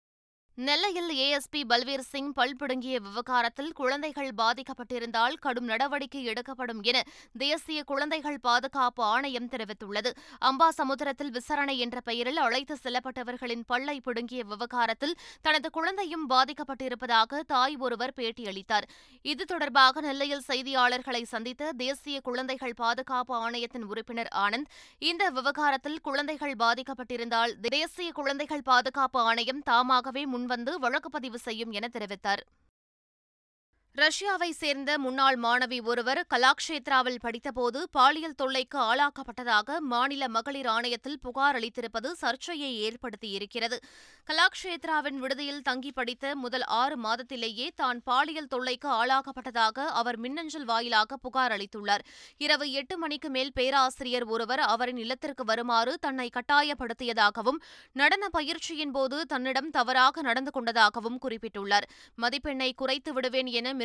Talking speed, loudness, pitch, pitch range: 110 wpm, -29 LUFS, 260 Hz, 240-285 Hz